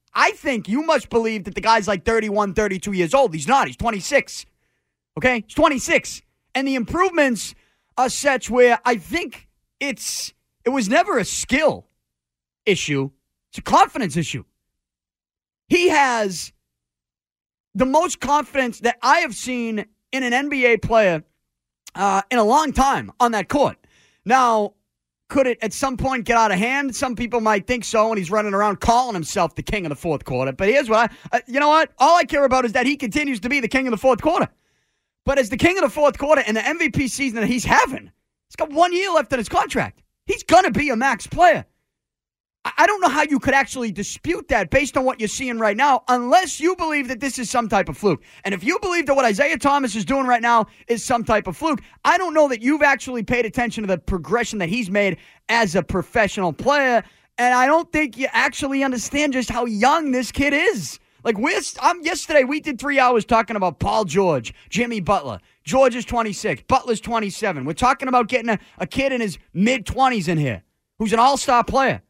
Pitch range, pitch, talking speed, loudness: 210-275 Hz, 245 Hz, 210 wpm, -19 LUFS